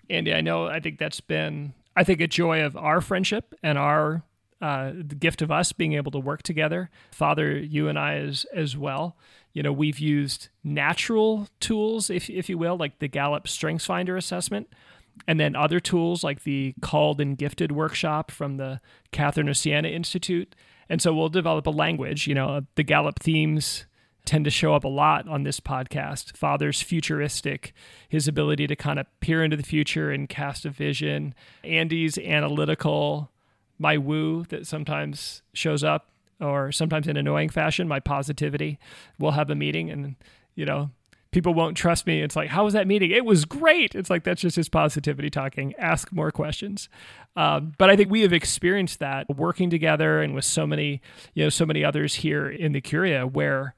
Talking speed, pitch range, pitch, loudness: 185 wpm, 140-165 Hz, 150 Hz, -24 LUFS